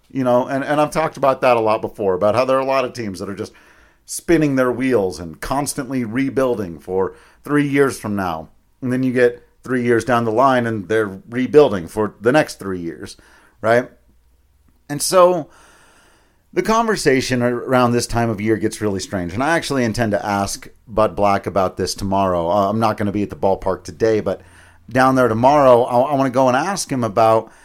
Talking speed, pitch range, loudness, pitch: 210 wpm, 100-135 Hz, -18 LUFS, 120 Hz